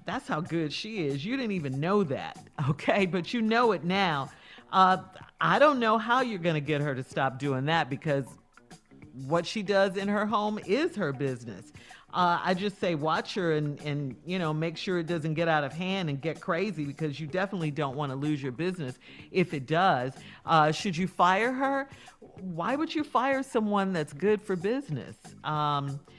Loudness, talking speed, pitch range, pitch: -28 LUFS, 200 wpm, 150-200 Hz, 170 Hz